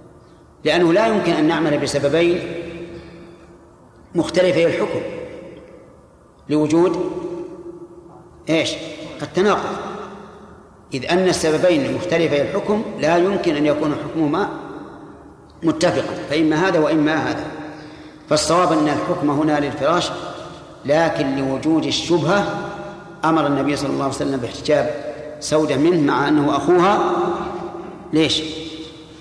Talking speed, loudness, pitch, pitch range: 95 wpm, -19 LUFS, 160 Hz, 150-185 Hz